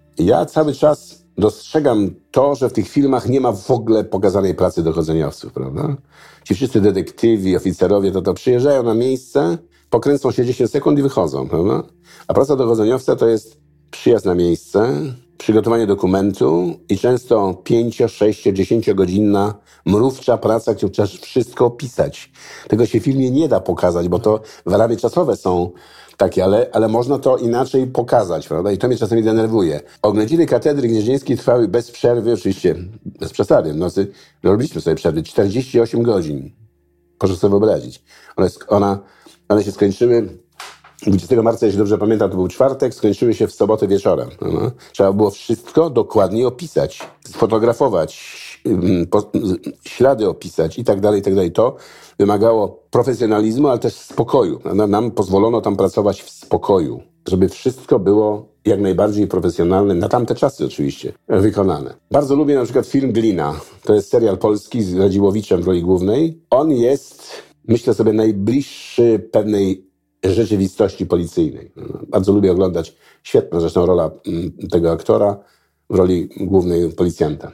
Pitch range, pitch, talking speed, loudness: 95-120 Hz, 105 Hz, 145 wpm, -16 LUFS